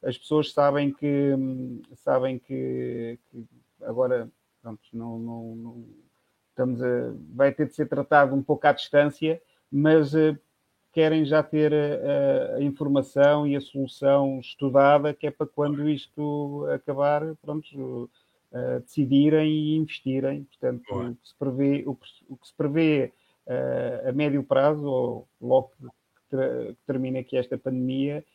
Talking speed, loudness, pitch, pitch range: 145 wpm, -25 LUFS, 140 Hz, 130-150 Hz